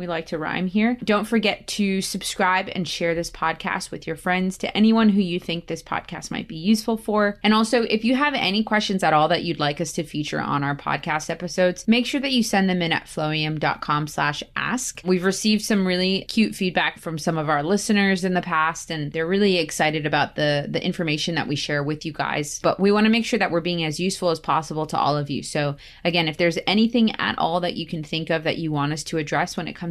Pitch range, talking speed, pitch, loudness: 160-200 Hz, 245 wpm, 175 Hz, -22 LUFS